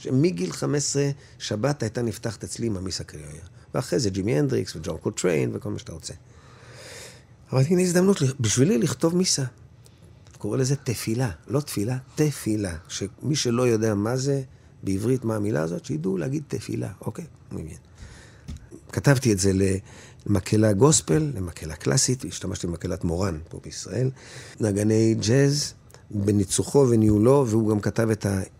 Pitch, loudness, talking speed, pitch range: 115 Hz, -24 LUFS, 145 wpm, 105-130 Hz